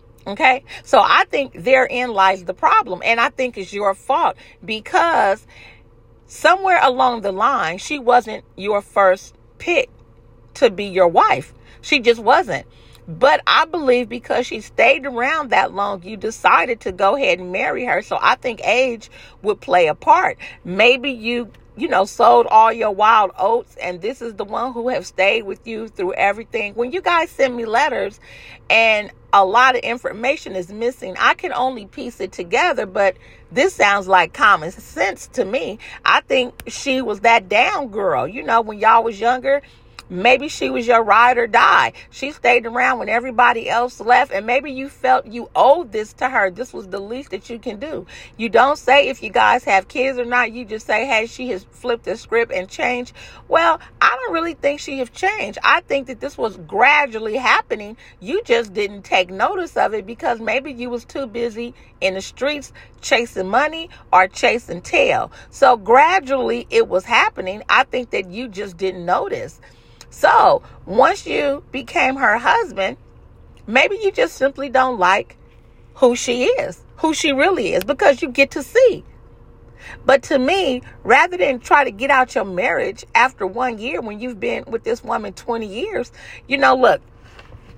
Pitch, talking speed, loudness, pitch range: 245 Hz, 180 wpm, -17 LUFS, 215-280 Hz